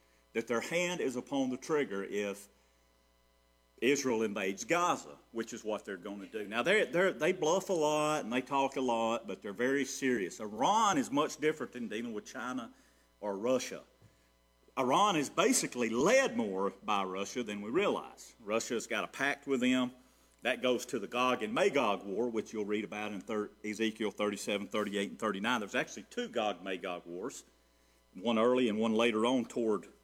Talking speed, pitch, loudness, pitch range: 180 wpm, 105 Hz, -33 LUFS, 95-125 Hz